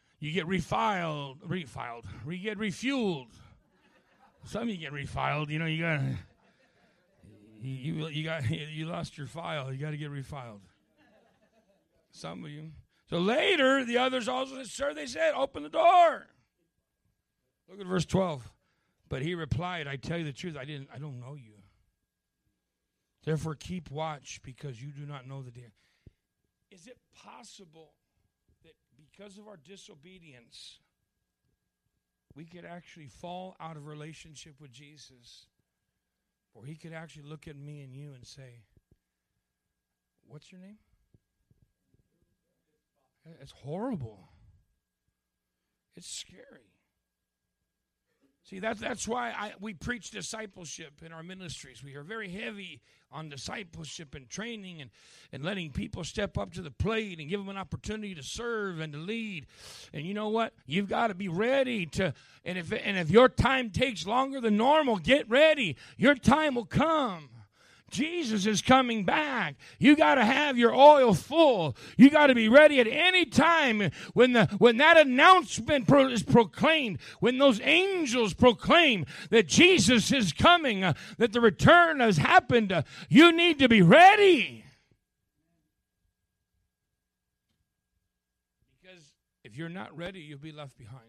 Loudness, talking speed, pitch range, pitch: -25 LUFS, 150 wpm, 140-230 Hz, 175 Hz